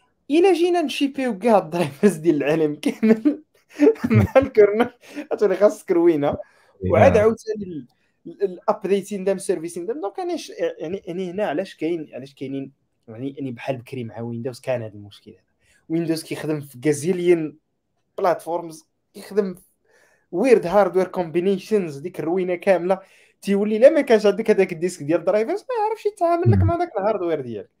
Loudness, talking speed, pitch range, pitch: -21 LUFS, 140 wpm, 155-240 Hz, 195 Hz